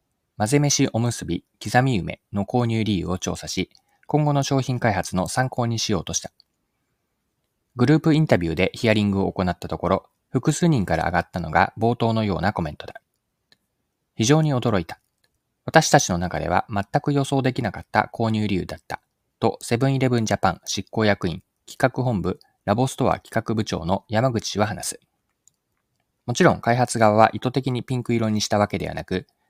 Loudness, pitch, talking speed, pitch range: -22 LUFS, 110 Hz, 350 characters per minute, 95-130 Hz